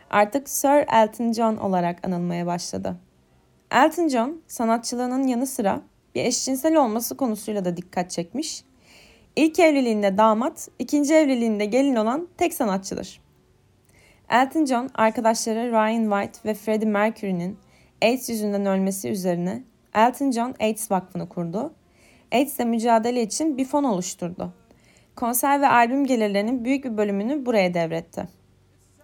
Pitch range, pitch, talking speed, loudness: 195-260 Hz, 225 Hz, 125 wpm, -23 LUFS